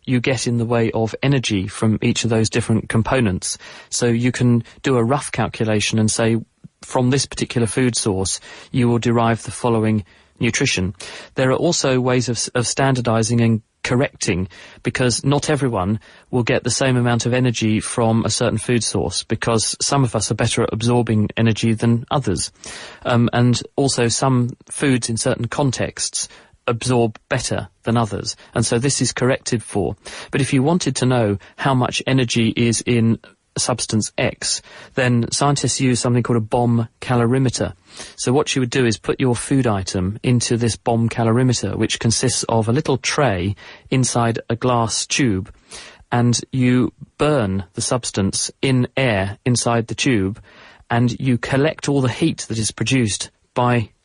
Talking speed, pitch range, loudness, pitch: 170 wpm, 110-125 Hz, -19 LUFS, 120 Hz